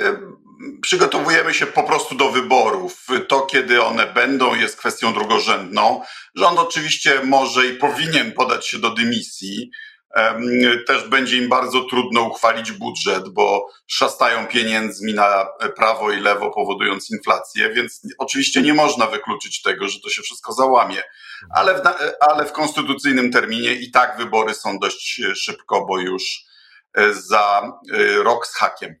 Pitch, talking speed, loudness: 135 Hz, 140 wpm, -17 LUFS